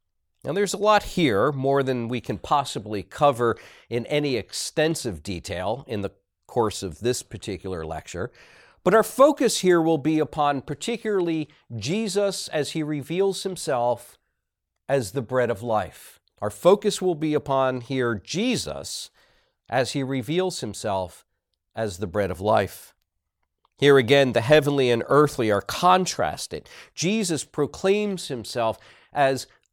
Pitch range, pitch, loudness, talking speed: 115-165 Hz, 140 Hz, -24 LUFS, 135 wpm